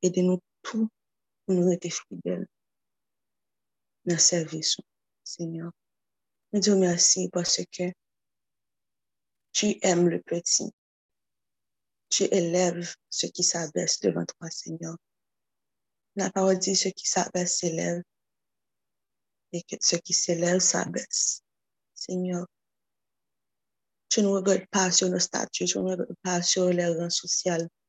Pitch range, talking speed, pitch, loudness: 170-185 Hz, 125 wpm, 175 Hz, -25 LUFS